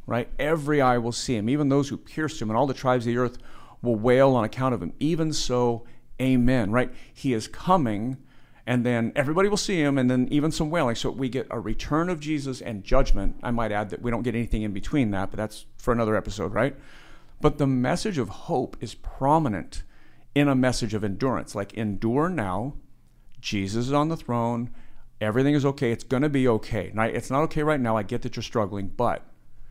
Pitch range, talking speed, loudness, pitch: 115-140 Hz, 215 wpm, -25 LUFS, 125 Hz